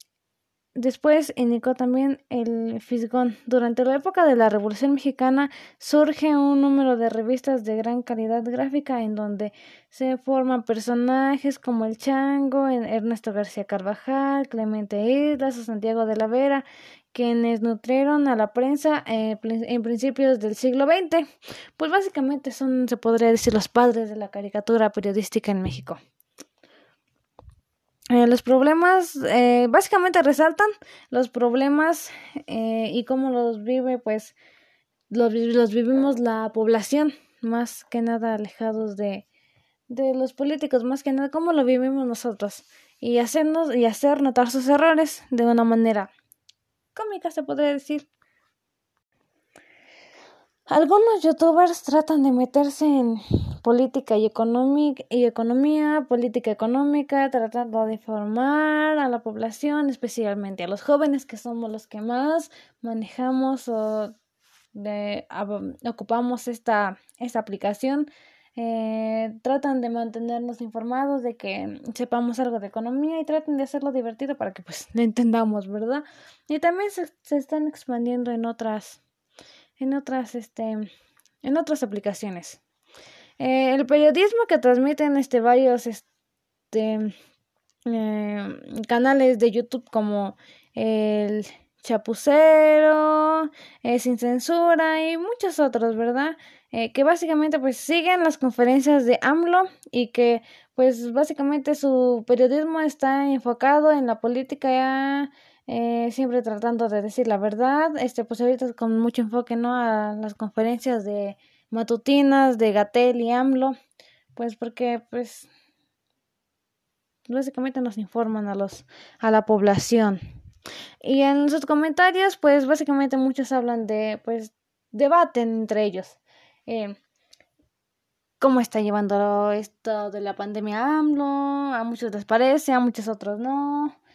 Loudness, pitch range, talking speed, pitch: -22 LUFS, 225-280 Hz, 130 wpm, 250 Hz